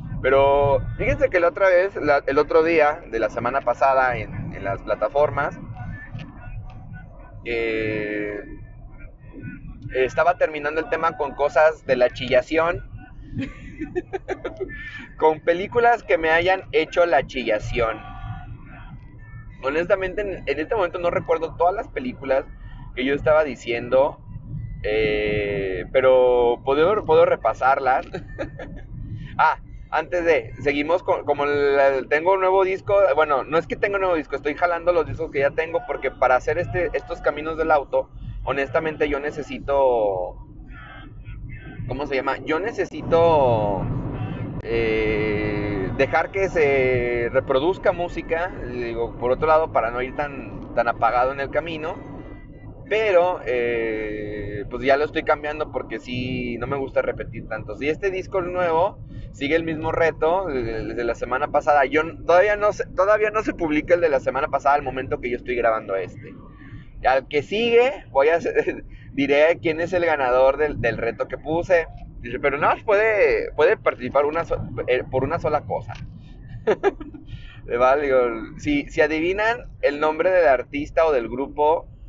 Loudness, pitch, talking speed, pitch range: -21 LUFS, 140 Hz, 150 wpm, 120-165 Hz